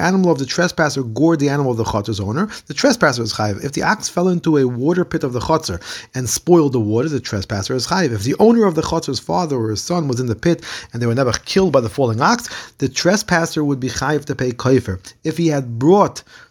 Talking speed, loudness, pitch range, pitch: 250 wpm, -17 LUFS, 115-165 Hz, 135 Hz